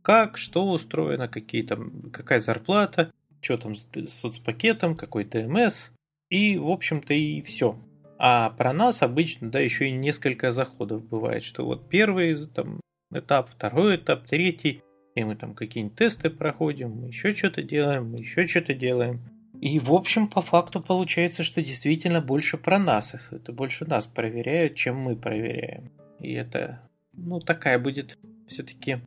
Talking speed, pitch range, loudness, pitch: 155 wpm, 120-175 Hz, -25 LUFS, 150 Hz